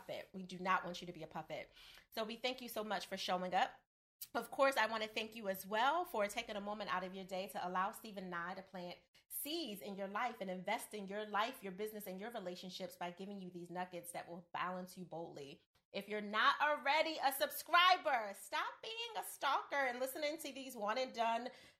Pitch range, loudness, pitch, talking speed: 185-250 Hz, -40 LUFS, 205 Hz, 225 wpm